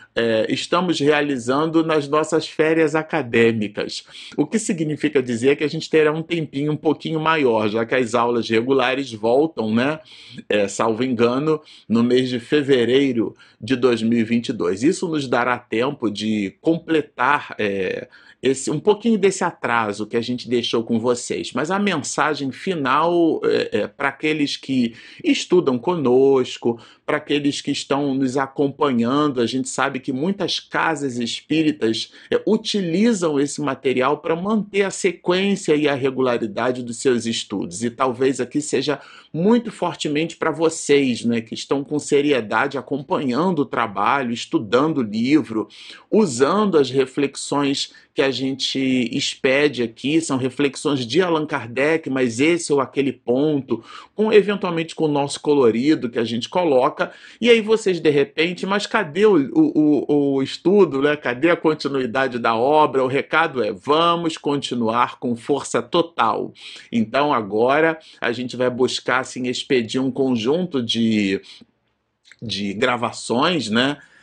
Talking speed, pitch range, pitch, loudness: 145 wpm, 125-160 Hz, 140 Hz, -20 LUFS